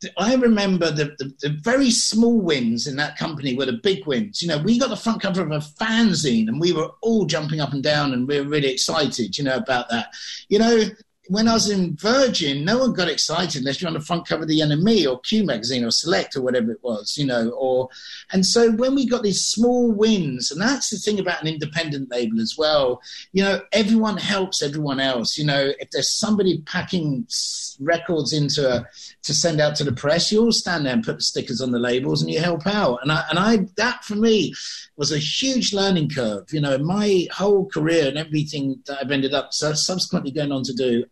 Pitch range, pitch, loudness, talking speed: 140-210 Hz, 165 Hz, -21 LUFS, 230 wpm